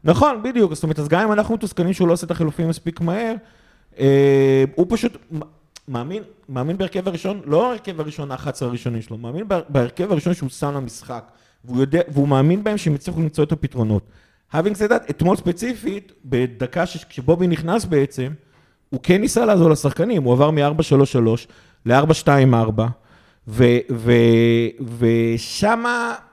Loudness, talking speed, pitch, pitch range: -19 LUFS, 155 wpm, 155 Hz, 130-180 Hz